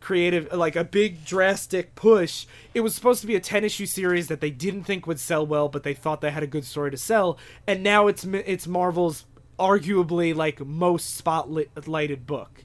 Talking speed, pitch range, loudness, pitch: 205 wpm, 150-195 Hz, -24 LUFS, 170 Hz